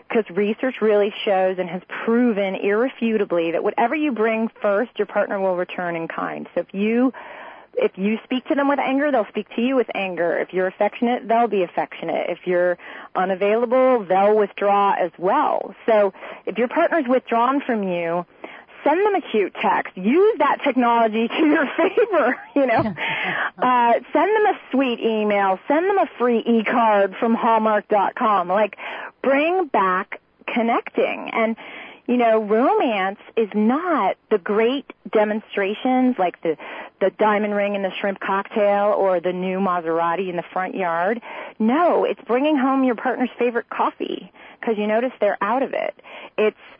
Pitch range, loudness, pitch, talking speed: 200-255 Hz, -20 LUFS, 225 Hz, 165 wpm